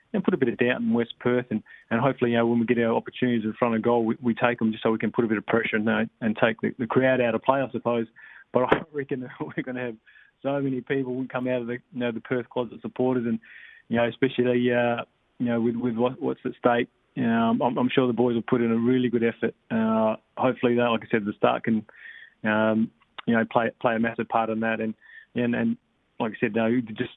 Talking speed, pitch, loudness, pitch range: 270 wpm, 120 Hz, -25 LUFS, 115-125 Hz